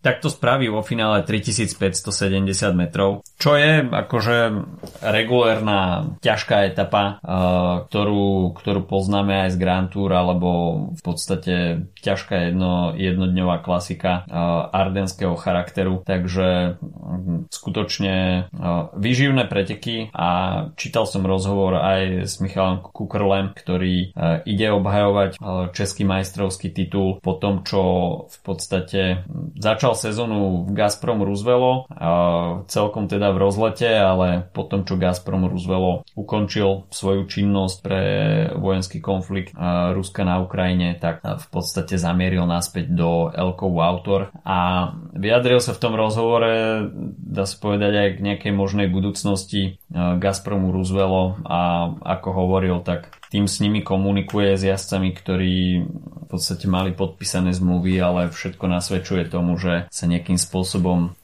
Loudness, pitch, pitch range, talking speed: -21 LUFS, 95 Hz, 90-100 Hz, 125 wpm